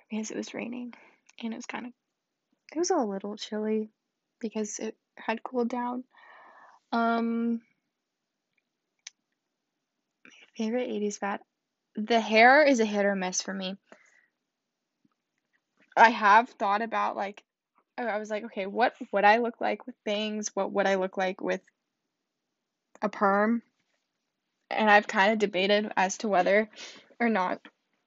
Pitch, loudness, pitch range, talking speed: 220 Hz, -27 LUFS, 205-240 Hz, 145 wpm